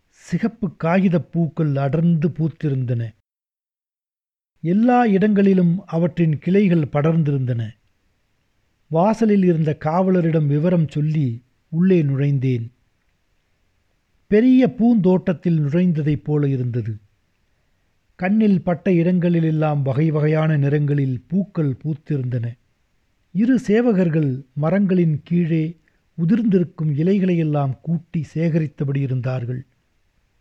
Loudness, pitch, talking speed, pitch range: -19 LUFS, 155 Hz, 75 wpm, 130-180 Hz